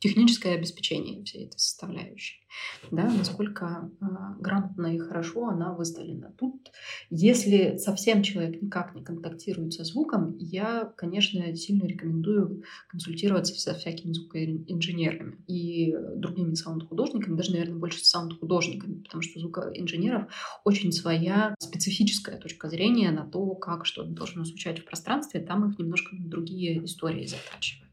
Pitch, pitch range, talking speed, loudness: 175 Hz, 170-200 Hz, 125 wpm, -28 LUFS